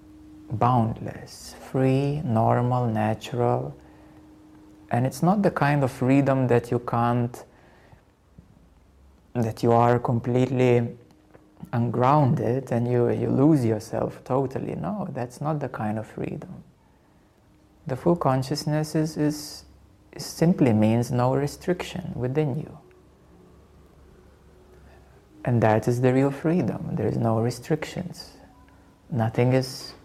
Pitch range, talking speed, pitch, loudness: 110-140 Hz, 110 wpm, 120 Hz, -24 LUFS